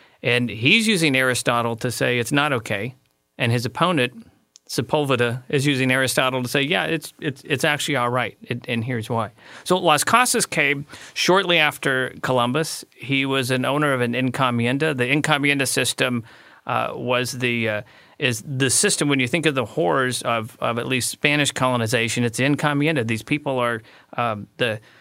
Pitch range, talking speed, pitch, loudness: 120-145 Hz, 175 wpm, 130 Hz, -21 LUFS